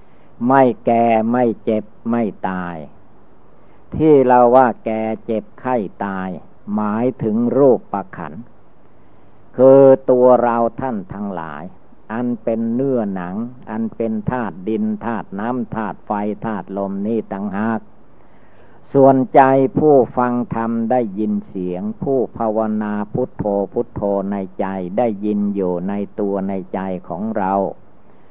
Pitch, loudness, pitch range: 110 Hz, -18 LUFS, 100-125 Hz